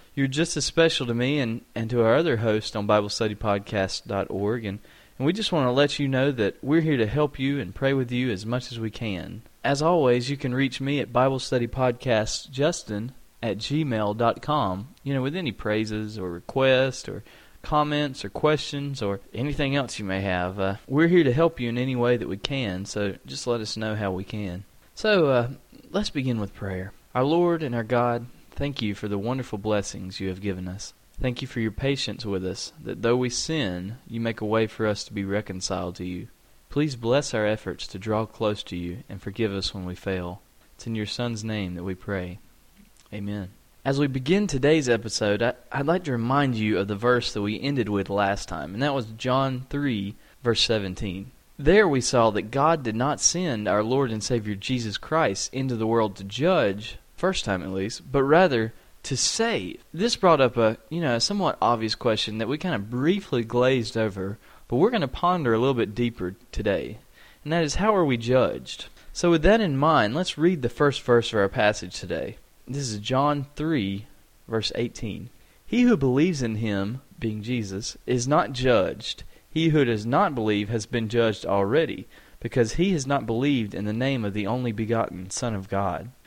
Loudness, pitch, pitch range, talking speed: -25 LUFS, 120 Hz, 105-140 Hz, 205 wpm